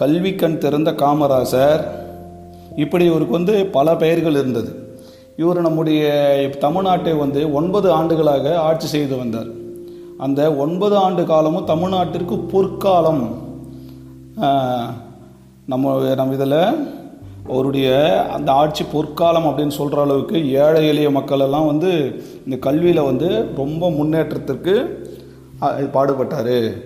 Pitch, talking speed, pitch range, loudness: 145 Hz, 100 wpm, 130-165 Hz, -17 LUFS